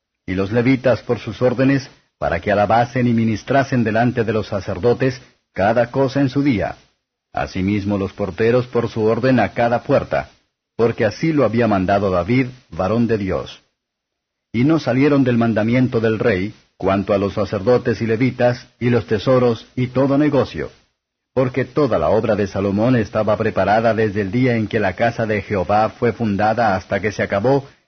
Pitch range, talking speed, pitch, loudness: 105-125 Hz, 170 wpm, 115 Hz, -18 LUFS